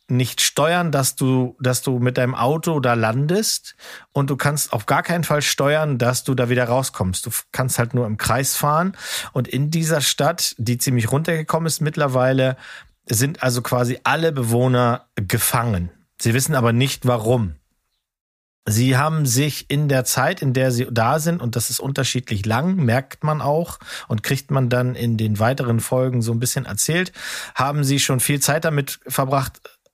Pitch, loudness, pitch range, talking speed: 130 Hz, -20 LUFS, 120-145 Hz, 180 wpm